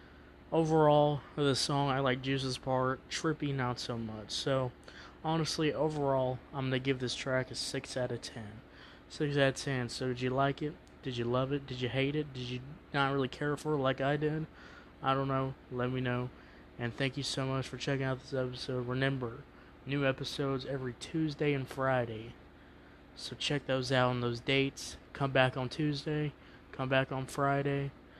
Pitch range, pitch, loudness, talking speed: 125-140 Hz, 135 Hz, -33 LUFS, 190 wpm